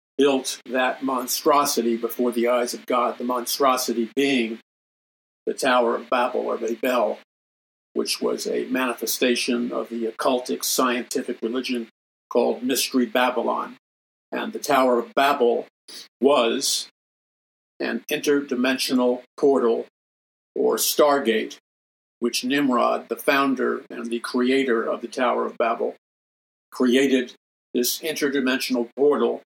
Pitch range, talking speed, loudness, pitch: 115-130 Hz, 115 wpm, -22 LUFS, 125 Hz